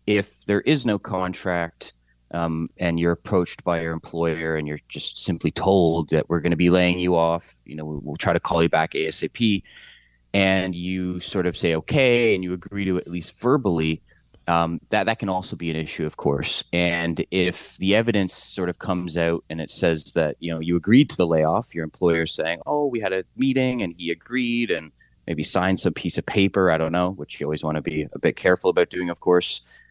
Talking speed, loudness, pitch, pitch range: 225 wpm, -23 LUFS, 85 Hz, 80-95 Hz